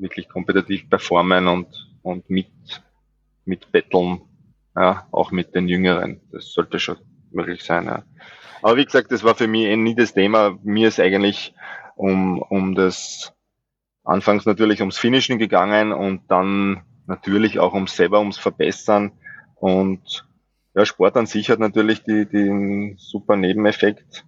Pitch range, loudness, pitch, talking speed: 95-105 Hz, -19 LUFS, 100 Hz, 150 wpm